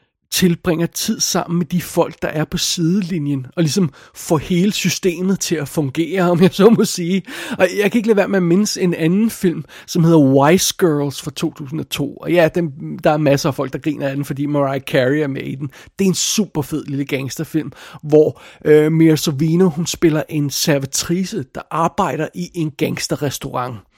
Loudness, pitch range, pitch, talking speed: -17 LUFS, 150-180 Hz, 165 Hz, 200 wpm